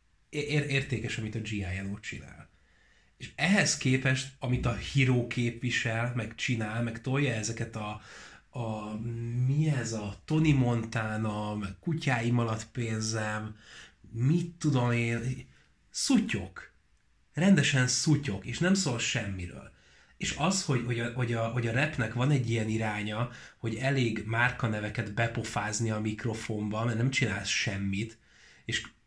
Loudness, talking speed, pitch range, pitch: -30 LUFS, 130 wpm, 110-130 Hz, 115 Hz